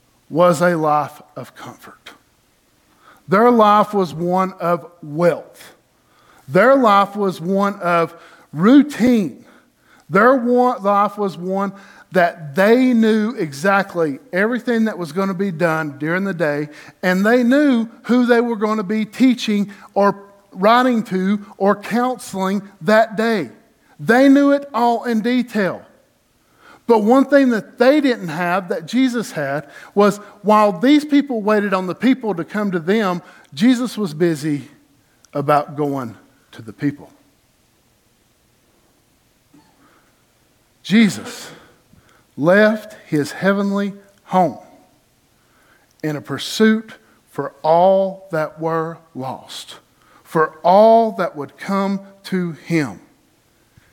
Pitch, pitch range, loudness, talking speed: 195 Hz, 165-225 Hz, -17 LUFS, 120 wpm